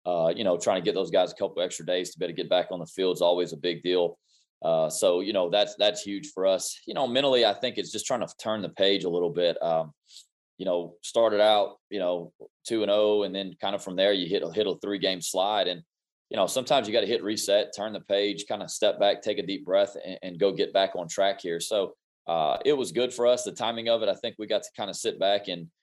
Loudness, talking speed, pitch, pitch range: -27 LUFS, 290 wpm, 100 Hz, 90-115 Hz